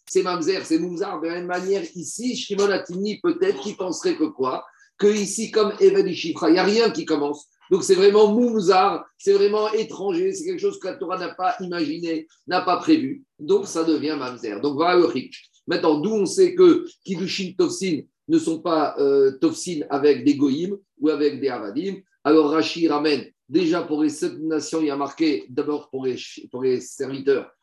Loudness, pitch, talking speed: -22 LUFS, 195 Hz, 190 wpm